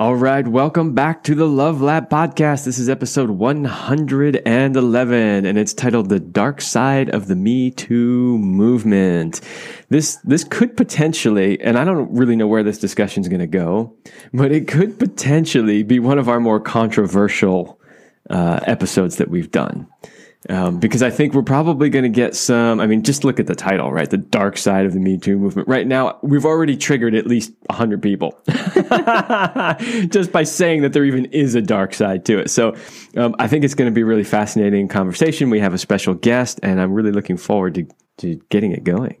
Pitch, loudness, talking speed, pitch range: 125 Hz, -17 LUFS, 195 wpm, 105-145 Hz